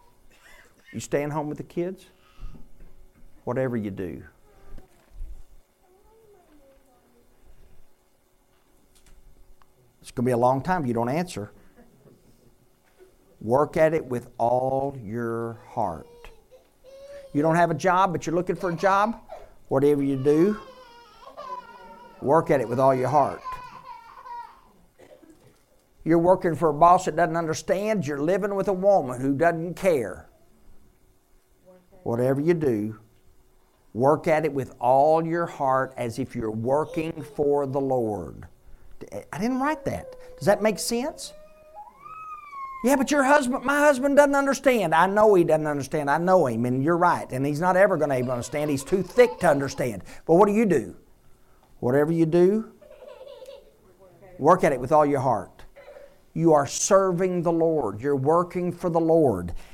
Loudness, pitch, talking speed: -23 LUFS, 170 Hz, 150 wpm